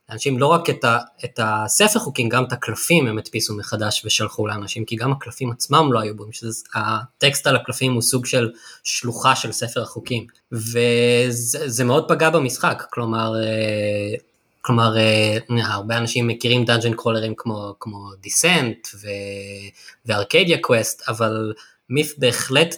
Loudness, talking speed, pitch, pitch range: -19 LUFS, 140 wpm, 115 Hz, 110-125 Hz